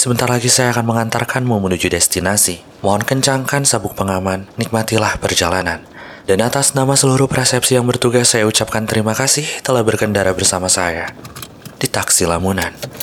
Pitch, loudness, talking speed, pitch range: 110 Hz, -15 LUFS, 145 wpm, 95-125 Hz